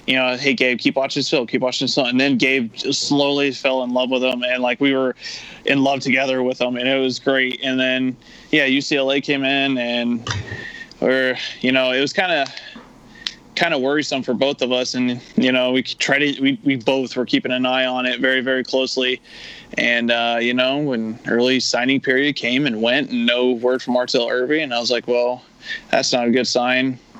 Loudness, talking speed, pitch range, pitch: -18 LUFS, 220 wpm, 125-135 Hz, 130 Hz